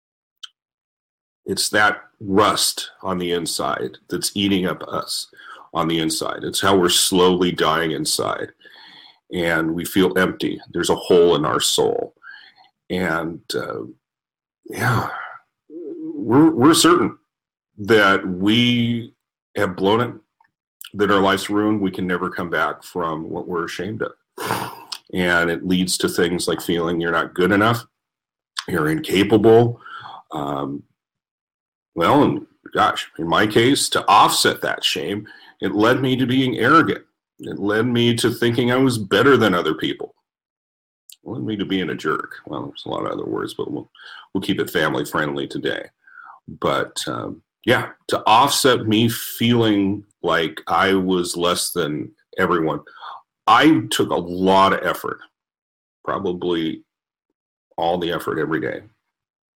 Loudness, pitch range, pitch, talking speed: -19 LUFS, 90-120 Hz, 100 Hz, 140 wpm